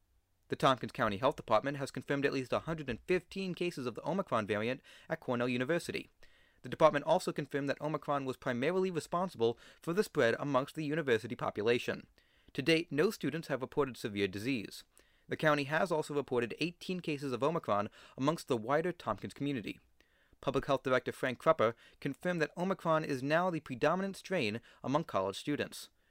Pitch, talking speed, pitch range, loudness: 140 Hz, 165 wpm, 125-160 Hz, -35 LUFS